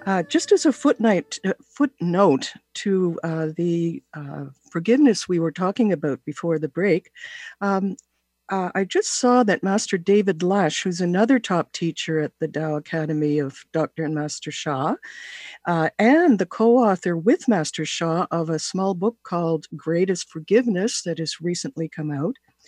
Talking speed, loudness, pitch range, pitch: 155 wpm, -22 LUFS, 160-210 Hz, 180 Hz